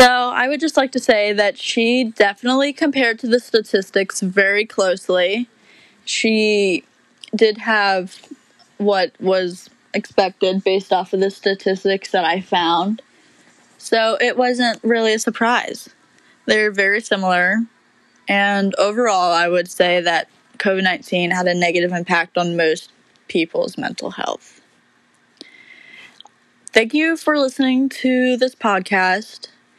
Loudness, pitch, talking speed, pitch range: -17 LUFS, 210 Hz, 125 wpm, 190-250 Hz